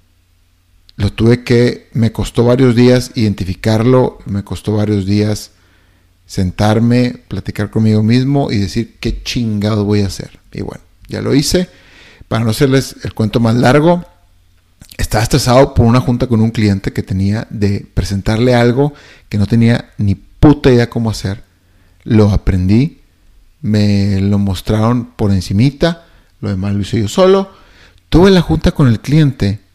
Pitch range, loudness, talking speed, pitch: 100-125 Hz, -13 LUFS, 150 wpm, 110 Hz